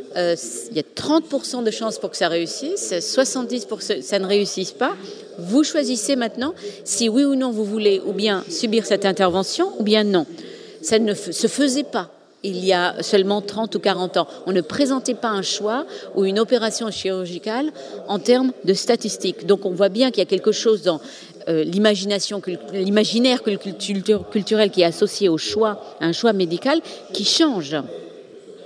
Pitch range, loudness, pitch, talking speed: 195-255 Hz, -20 LUFS, 215 Hz, 175 wpm